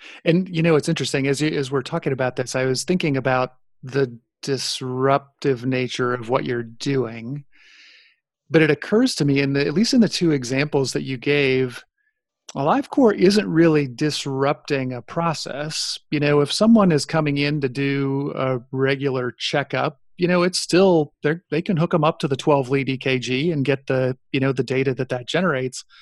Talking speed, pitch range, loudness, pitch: 190 wpm, 130-165 Hz, -21 LUFS, 140 Hz